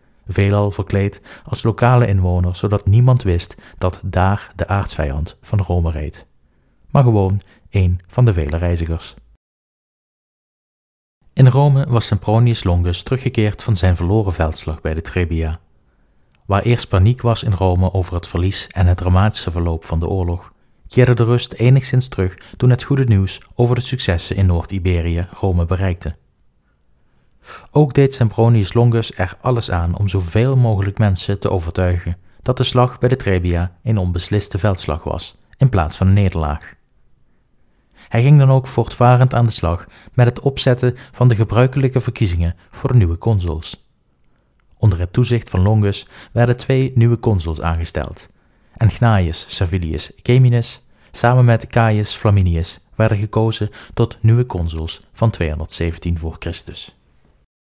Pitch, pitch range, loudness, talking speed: 100 Hz, 85-115 Hz, -17 LUFS, 145 wpm